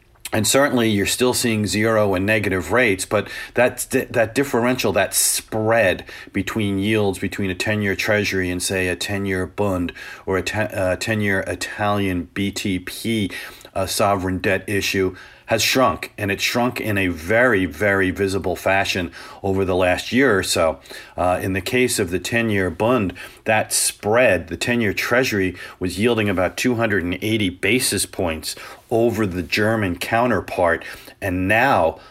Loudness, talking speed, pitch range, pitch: -20 LUFS, 155 wpm, 95-115 Hz, 100 Hz